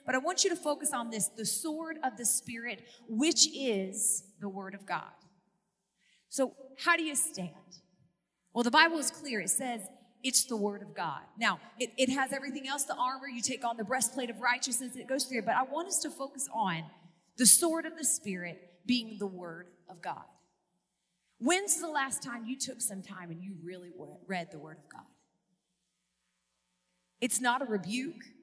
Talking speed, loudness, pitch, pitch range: 190 wpm, -30 LUFS, 235 Hz, 185-265 Hz